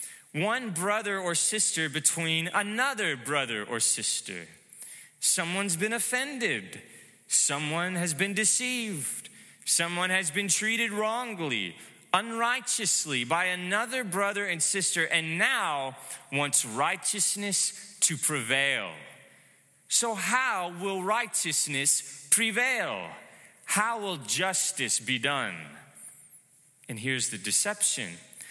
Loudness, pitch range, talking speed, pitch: -26 LUFS, 145-210 Hz, 100 wpm, 180 Hz